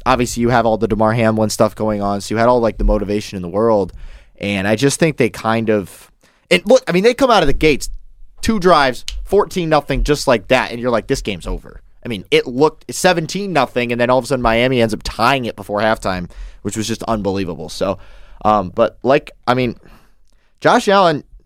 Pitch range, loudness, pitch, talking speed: 105-135 Hz, -16 LUFS, 115 Hz, 225 wpm